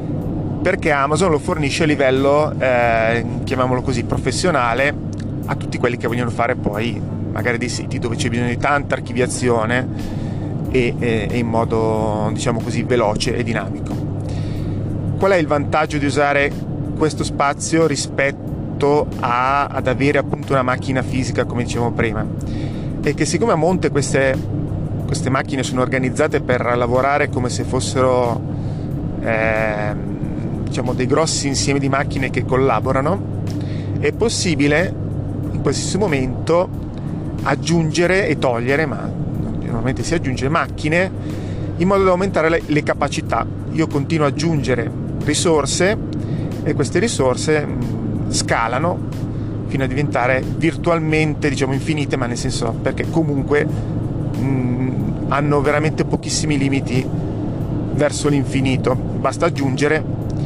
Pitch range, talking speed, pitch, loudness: 120-145 Hz, 125 wpm, 135 Hz, -19 LUFS